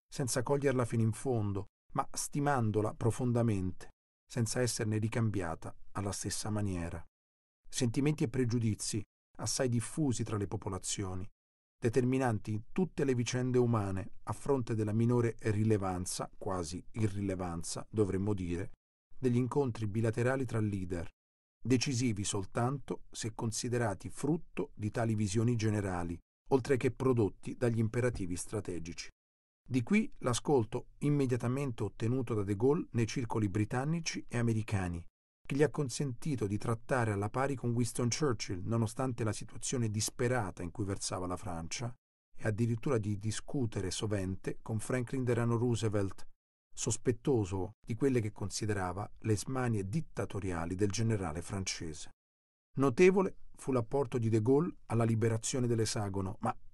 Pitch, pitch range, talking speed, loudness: 115 Hz, 100-125 Hz, 125 wpm, -34 LUFS